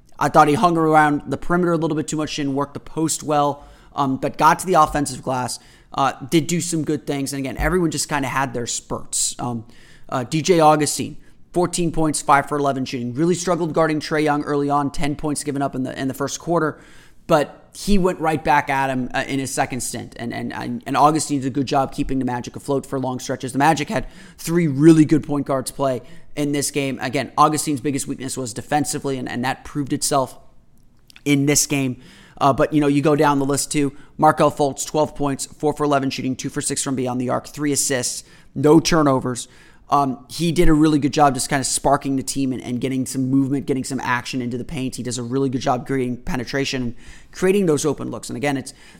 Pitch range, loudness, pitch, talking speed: 130-150 Hz, -20 LUFS, 140 Hz, 230 wpm